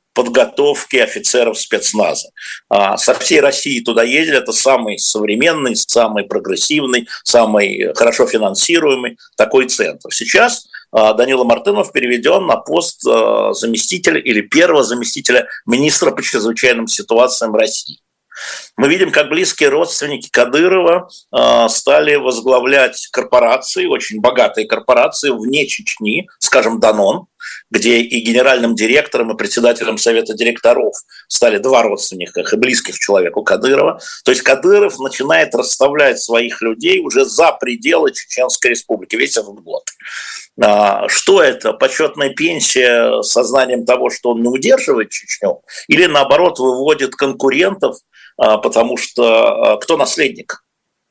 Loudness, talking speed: -12 LUFS, 115 wpm